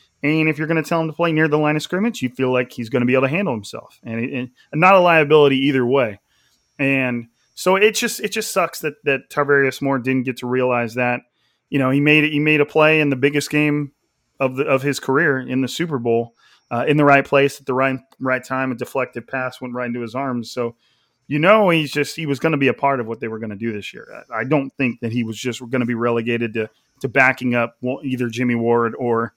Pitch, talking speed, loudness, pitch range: 135 Hz, 265 wpm, -19 LUFS, 120-150 Hz